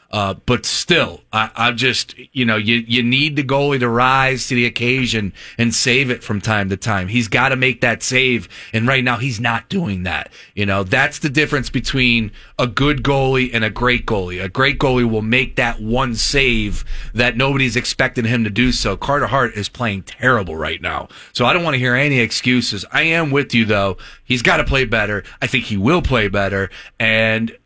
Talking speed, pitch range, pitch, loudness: 215 wpm, 110-130 Hz, 120 Hz, -16 LUFS